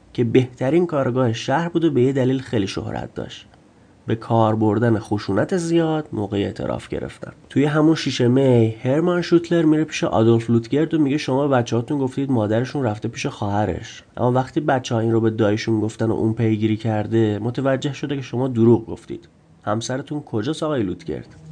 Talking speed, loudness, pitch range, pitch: 175 wpm, -20 LUFS, 110-145 Hz, 125 Hz